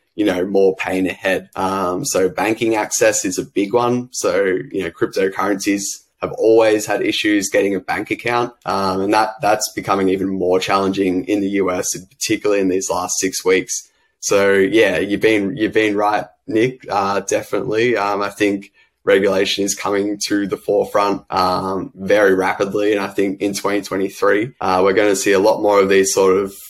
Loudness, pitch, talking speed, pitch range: -17 LUFS, 100 Hz, 185 wpm, 95-110 Hz